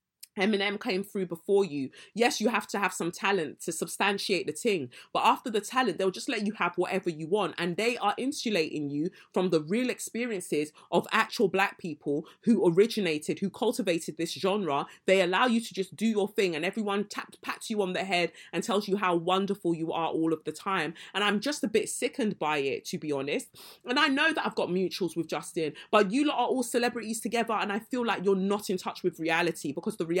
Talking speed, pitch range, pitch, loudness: 225 wpm, 175-220 Hz, 195 Hz, -29 LUFS